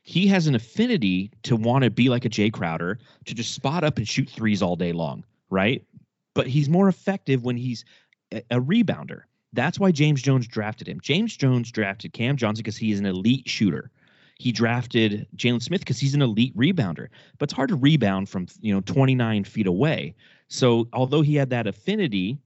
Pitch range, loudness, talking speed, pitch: 110-150 Hz, -23 LUFS, 200 wpm, 125 Hz